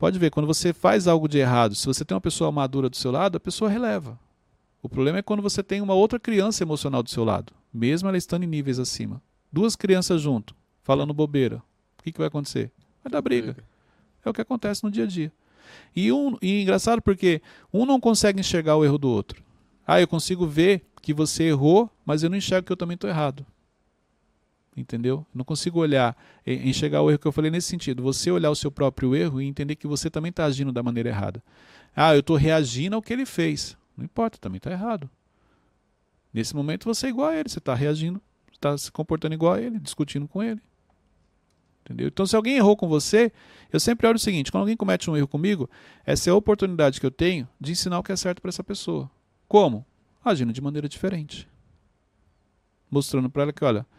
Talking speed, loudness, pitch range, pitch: 215 wpm, -24 LUFS, 130-185 Hz, 155 Hz